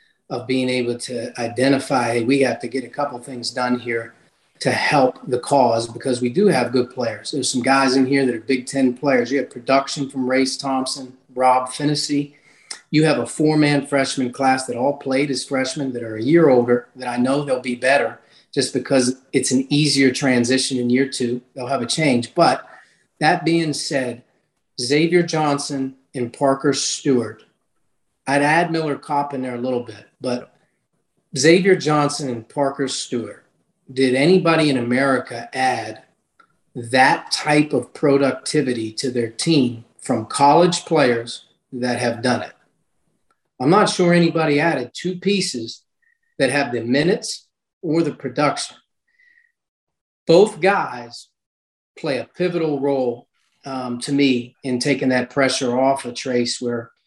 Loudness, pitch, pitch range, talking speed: -19 LUFS, 135 Hz, 125-145 Hz, 160 wpm